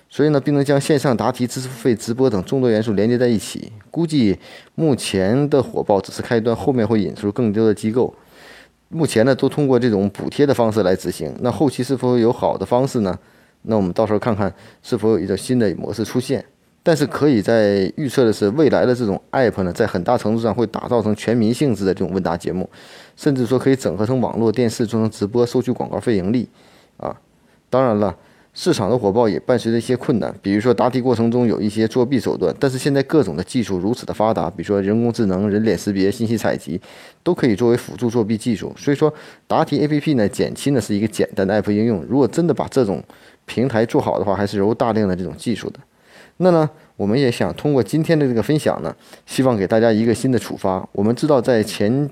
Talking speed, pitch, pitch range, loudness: 350 characters per minute, 115 Hz, 105-130 Hz, -19 LUFS